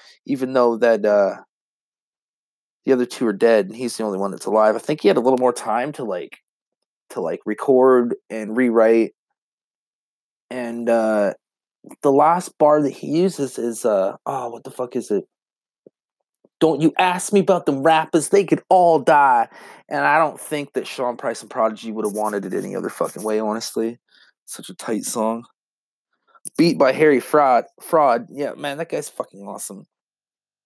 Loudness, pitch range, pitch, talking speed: -19 LUFS, 110-160 Hz, 125 Hz, 180 wpm